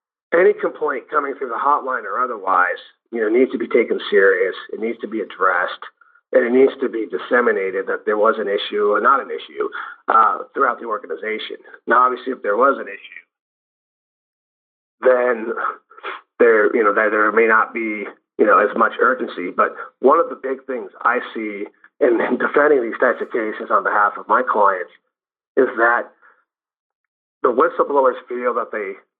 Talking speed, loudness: 175 wpm, -18 LUFS